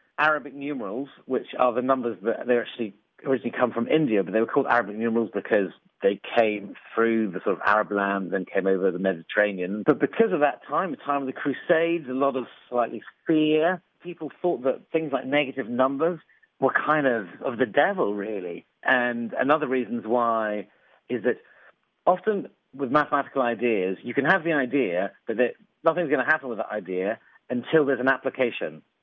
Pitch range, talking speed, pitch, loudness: 110-145 Hz, 185 wpm, 125 Hz, -25 LUFS